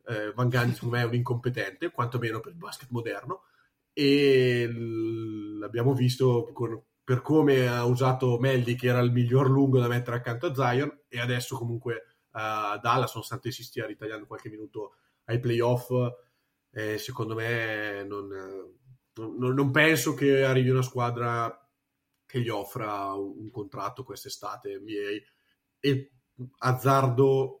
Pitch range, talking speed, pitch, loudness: 115-135 Hz, 145 wpm, 120 Hz, -27 LUFS